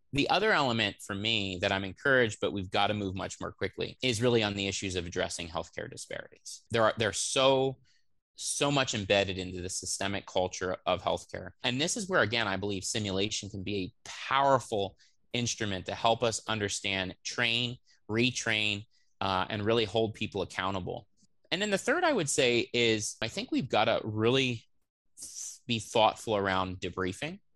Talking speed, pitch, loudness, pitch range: 180 wpm, 105 Hz, -30 LUFS, 95-120 Hz